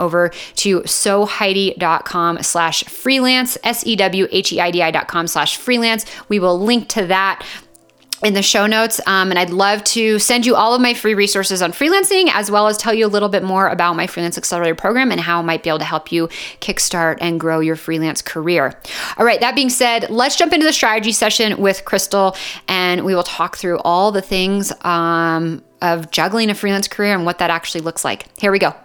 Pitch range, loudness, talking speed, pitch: 170-220 Hz, -15 LUFS, 200 wpm, 195 Hz